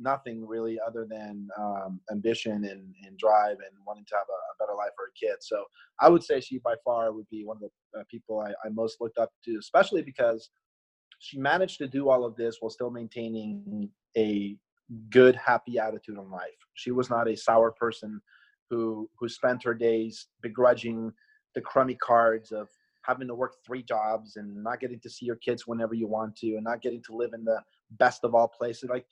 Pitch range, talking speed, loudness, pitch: 110-125 Hz, 210 wpm, -28 LUFS, 115 Hz